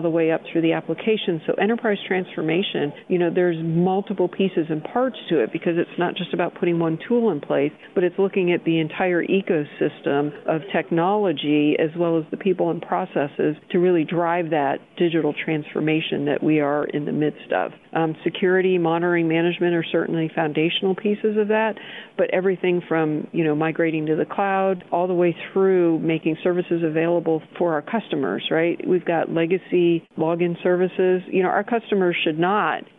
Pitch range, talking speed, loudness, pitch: 160-185 Hz, 180 wpm, -22 LUFS, 175 Hz